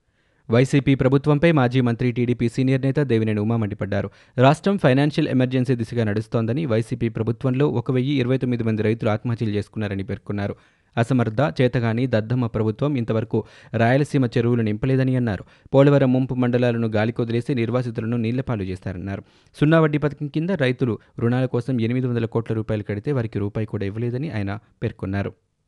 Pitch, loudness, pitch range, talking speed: 120 Hz, -22 LUFS, 110-130 Hz, 140 wpm